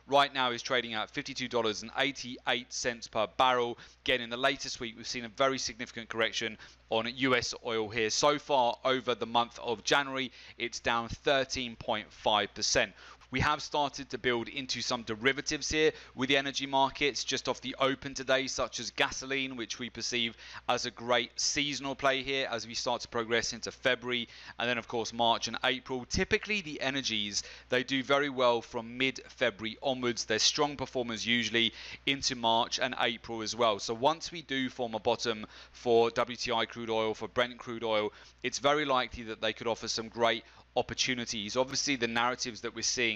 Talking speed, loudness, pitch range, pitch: 180 wpm, -31 LUFS, 115-135 Hz, 125 Hz